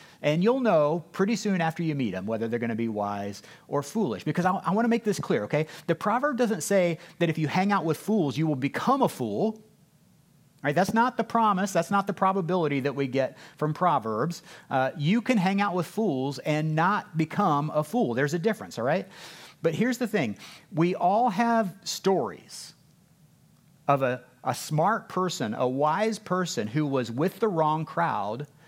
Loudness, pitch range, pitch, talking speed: -27 LUFS, 150-205 Hz, 165 Hz, 200 wpm